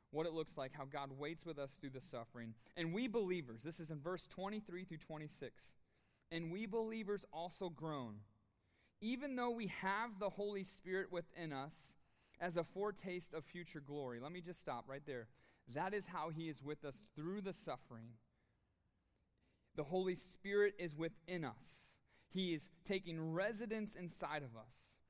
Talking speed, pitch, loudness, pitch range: 170 wpm, 165 Hz, -46 LUFS, 135-185 Hz